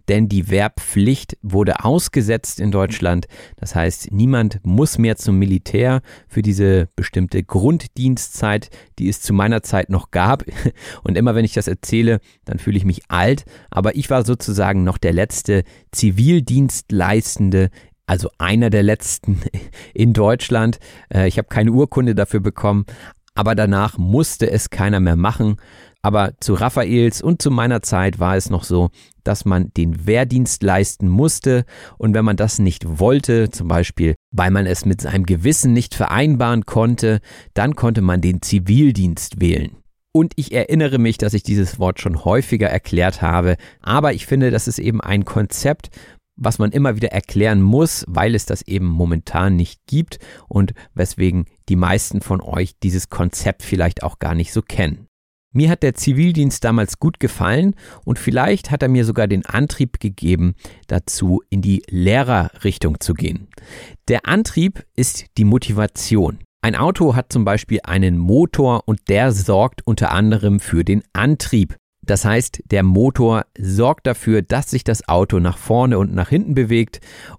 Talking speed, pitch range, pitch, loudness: 160 wpm, 95-120 Hz, 105 Hz, -17 LUFS